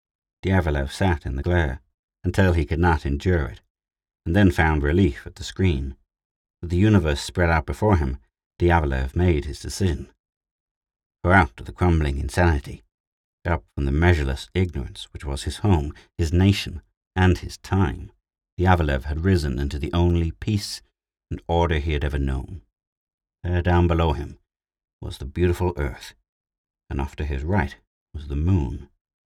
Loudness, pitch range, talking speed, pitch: -23 LUFS, 70-90 Hz, 160 wpm, 85 Hz